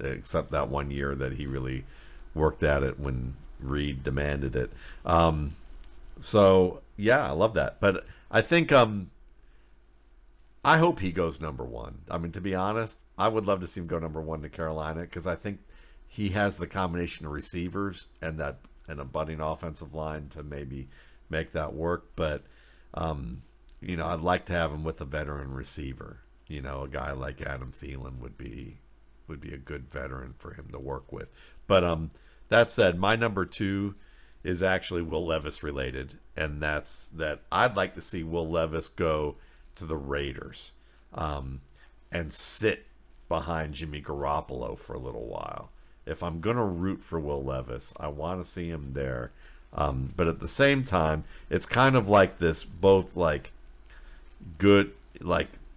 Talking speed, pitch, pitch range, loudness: 175 wpm, 80 Hz, 70-90 Hz, -29 LUFS